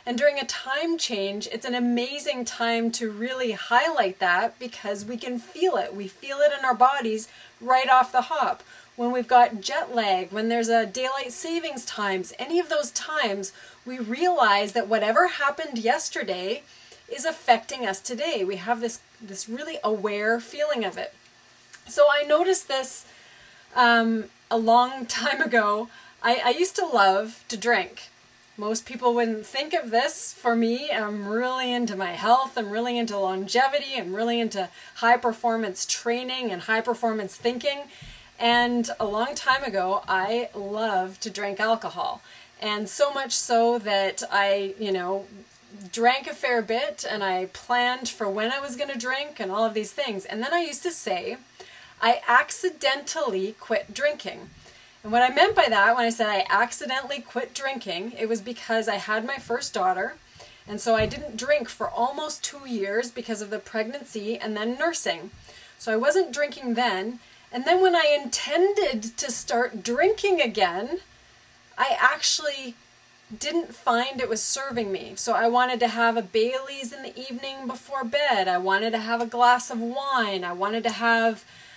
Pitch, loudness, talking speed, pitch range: 240 Hz, -24 LUFS, 170 wpm, 220-270 Hz